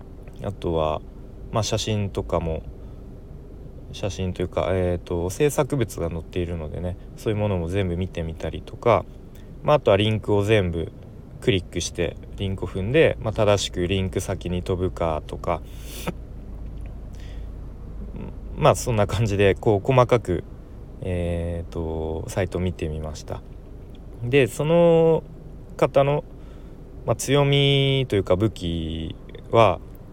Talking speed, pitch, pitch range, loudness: 255 characters per minute, 95 Hz, 85-115 Hz, -23 LUFS